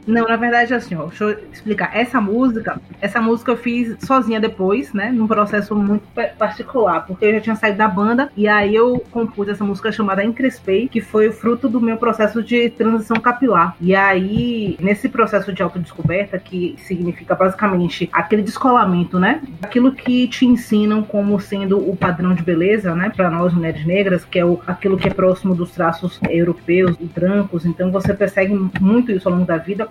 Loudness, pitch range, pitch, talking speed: -17 LUFS, 185-225 Hz, 205 Hz, 190 wpm